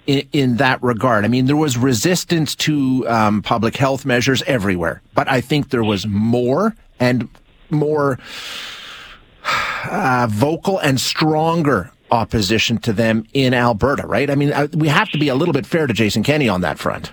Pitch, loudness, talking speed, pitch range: 130 Hz, -17 LUFS, 175 wpm, 115-150 Hz